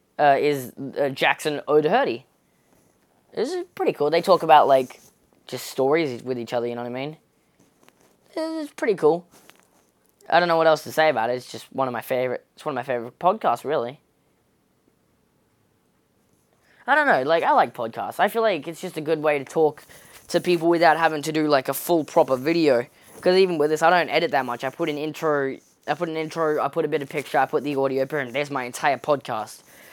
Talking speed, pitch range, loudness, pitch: 220 wpm, 135-165 Hz, -22 LUFS, 155 Hz